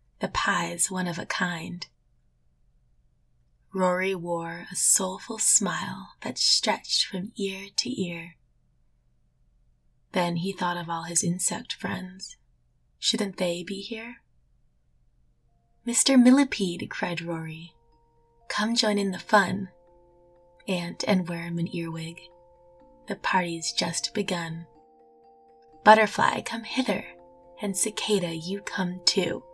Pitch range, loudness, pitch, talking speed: 155-195 Hz, -26 LUFS, 175 Hz, 110 wpm